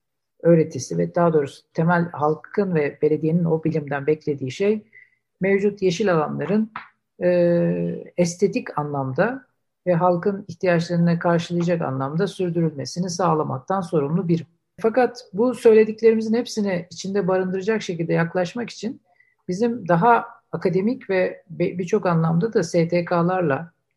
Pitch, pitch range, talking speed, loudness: 180 Hz, 165-205 Hz, 110 wpm, -22 LUFS